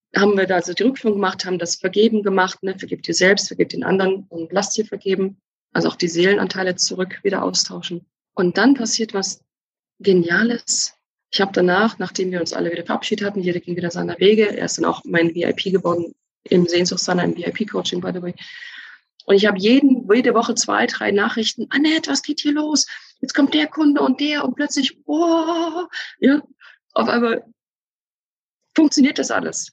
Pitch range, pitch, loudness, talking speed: 185-270 Hz, 205 Hz, -19 LUFS, 185 wpm